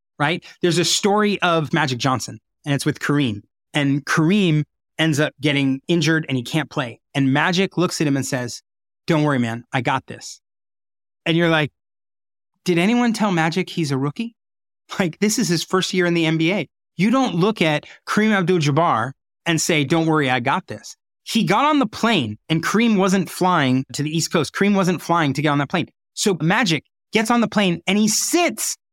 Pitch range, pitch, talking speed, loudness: 140-195 Hz, 165 Hz, 200 wpm, -19 LUFS